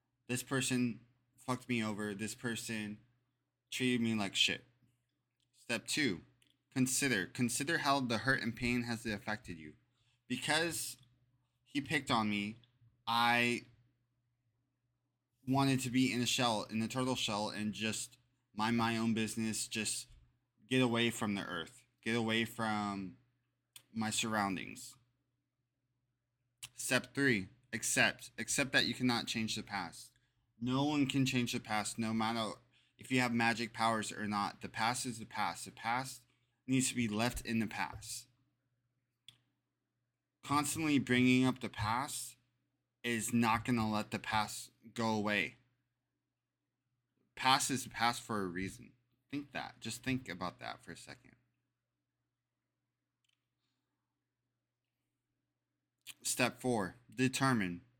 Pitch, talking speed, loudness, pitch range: 125 Hz, 130 wpm, -35 LUFS, 115-130 Hz